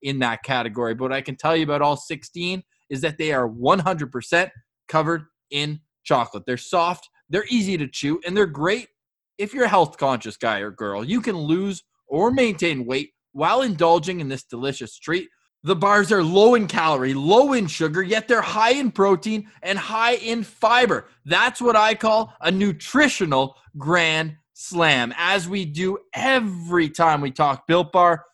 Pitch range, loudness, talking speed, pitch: 140-205 Hz, -21 LUFS, 180 wpm, 170 Hz